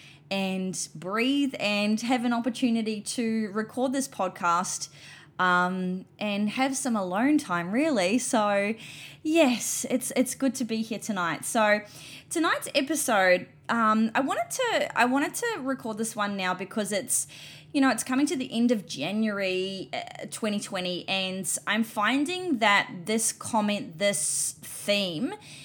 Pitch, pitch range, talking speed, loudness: 215 Hz, 185-255 Hz, 140 wpm, -27 LUFS